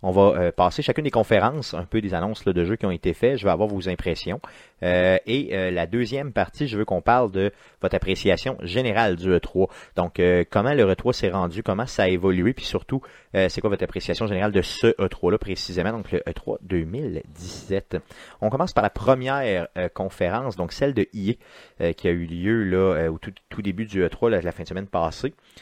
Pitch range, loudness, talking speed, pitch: 90-115 Hz, -23 LUFS, 225 wpm, 95 Hz